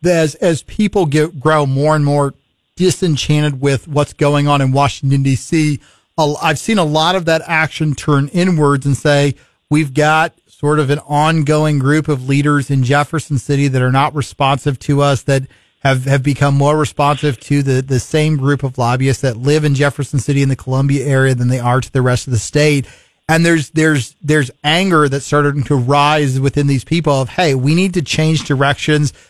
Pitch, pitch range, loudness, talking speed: 145 Hz, 140-155 Hz, -14 LUFS, 195 wpm